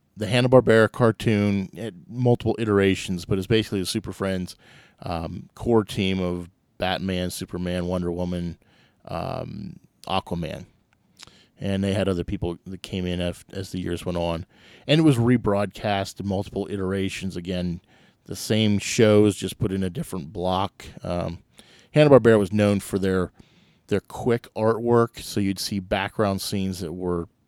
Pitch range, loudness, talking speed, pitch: 90-110 Hz, -24 LUFS, 155 wpm, 95 Hz